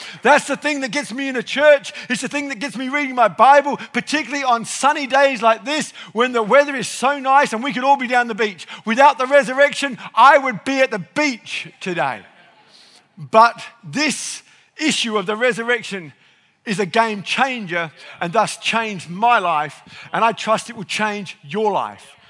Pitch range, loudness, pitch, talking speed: 210-275 Hz, -17 LUFS, 235 Hz, 190 wpm